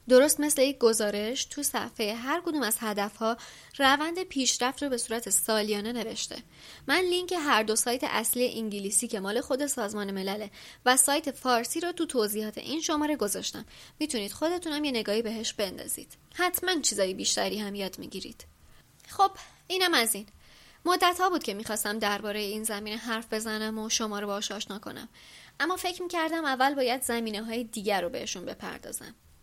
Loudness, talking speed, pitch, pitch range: -28 LUFS, 165 wpm, 235 Hz, 215-295 Hz